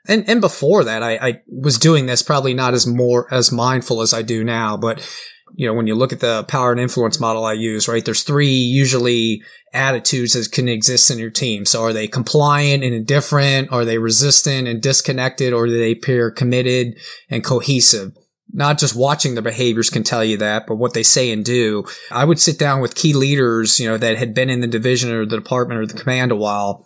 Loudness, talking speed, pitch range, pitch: -15 LUFS, 225 wpm, 115-135 Hz, 125 Hz